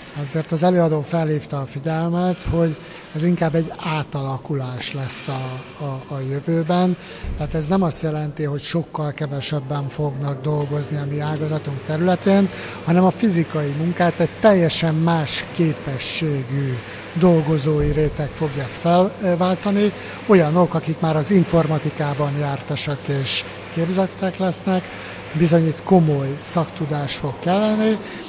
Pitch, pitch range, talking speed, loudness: 155 Hz, 145-175 Hz, 120 wpm, -20 LUFS